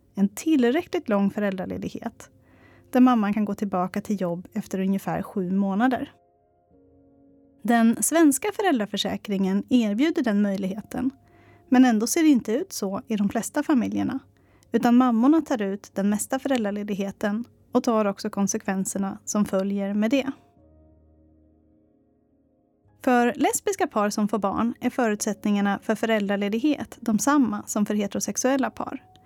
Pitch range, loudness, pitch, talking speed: 195-250 Hz, -24 LUFS, 215 Hz, 130 wpm